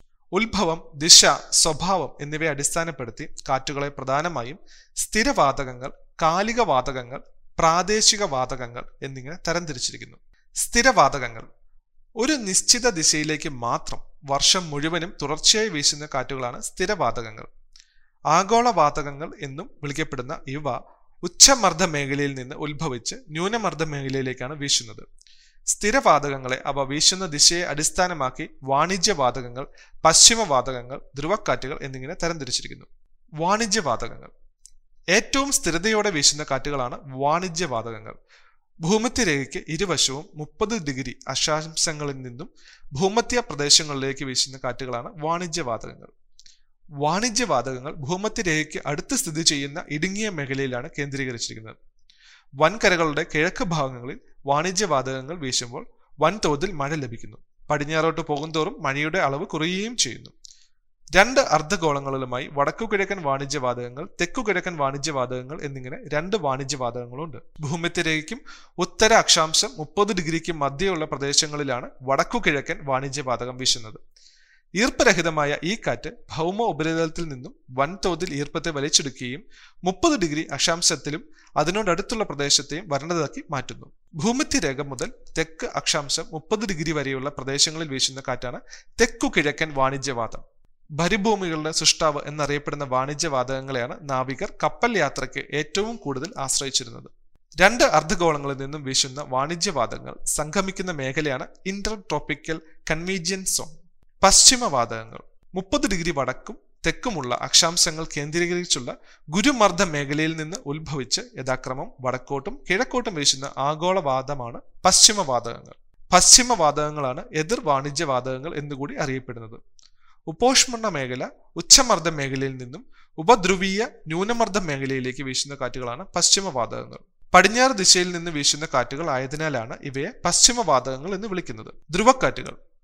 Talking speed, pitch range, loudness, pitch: 95 wpm, 135-185 Hz, -21 LUFS, 155 Hz